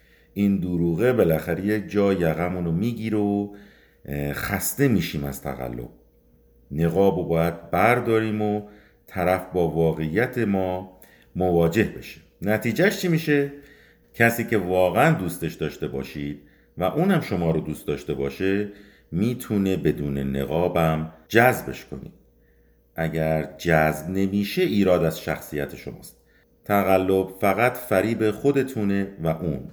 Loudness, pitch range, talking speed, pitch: -23 LUFS, 80-105 Hz, 115 wpm, 90 Hz